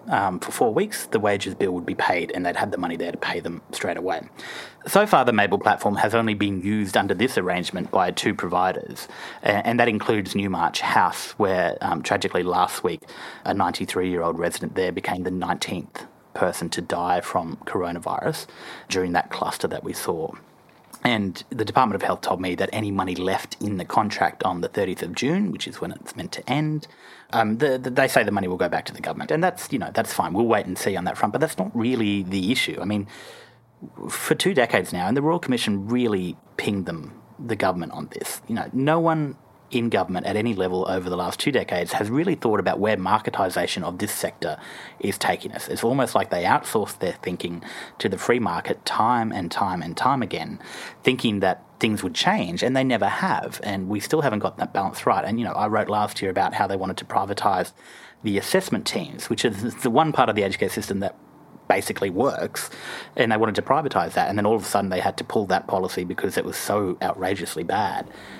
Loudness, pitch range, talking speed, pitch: -24 LUFS, 90-115 Hz, 220 wpm, 100 Hz